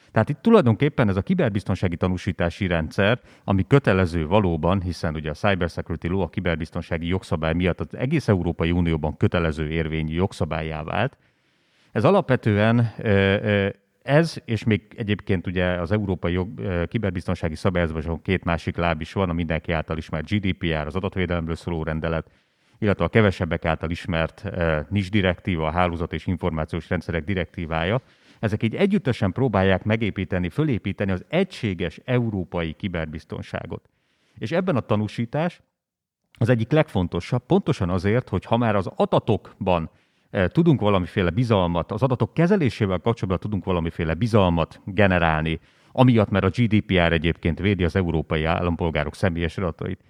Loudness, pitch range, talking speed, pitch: -23 LUFS, 85-110 Hz, 135 wpm, 95 Hz